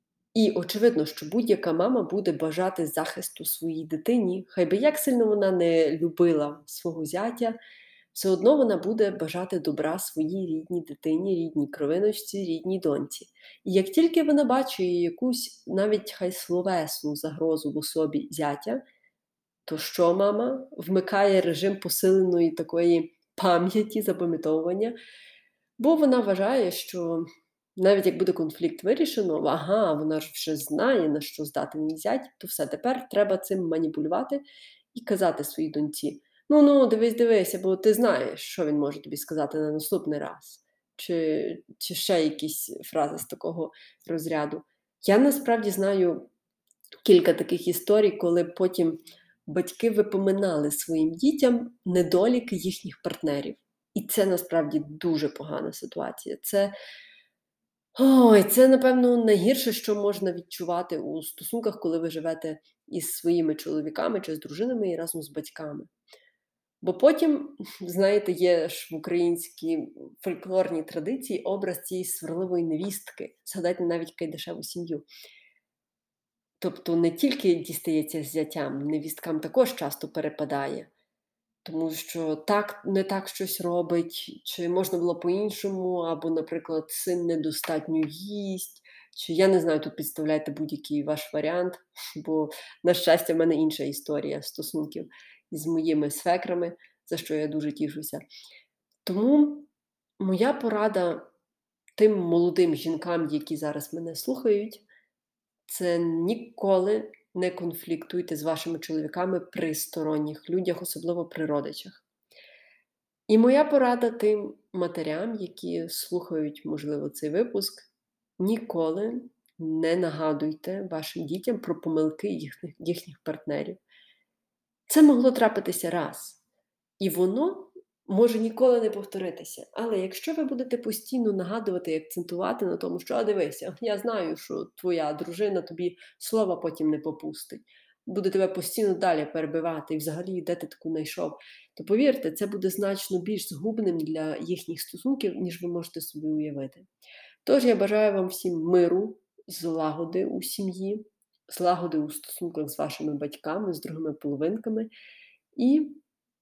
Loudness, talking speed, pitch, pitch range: -26 LUFS, 130 wpm, 180 Hz, 160-210 Hz